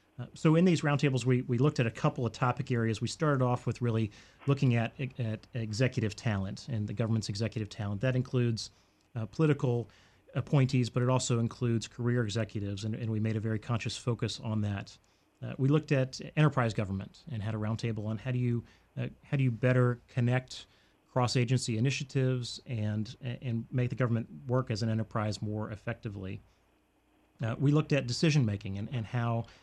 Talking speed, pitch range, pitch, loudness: 190 wpm, 110-130 Hz, 120 Hz, -32 LUFS